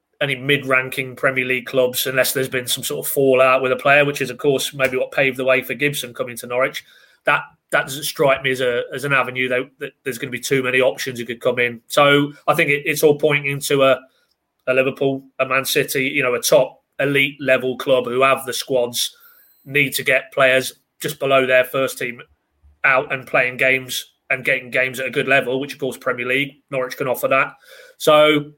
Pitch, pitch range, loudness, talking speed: 135 Hz, 130-140 Hz, -18 LUFS, 225 wpm